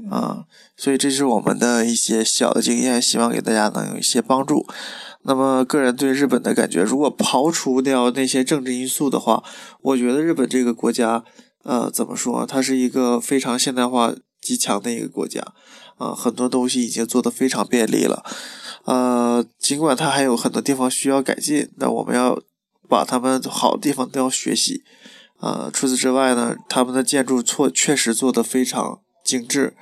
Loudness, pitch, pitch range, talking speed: -19 LUFS, 130 Hz, 120-135 Hz, 280 characters per minute